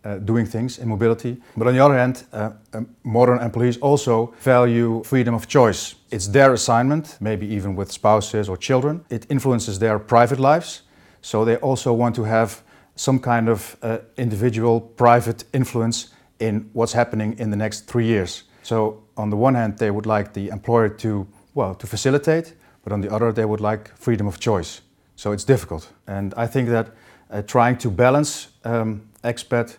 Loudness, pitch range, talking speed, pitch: -20 LUFS, 110-125 Hz, 185 wpm, 115 Hz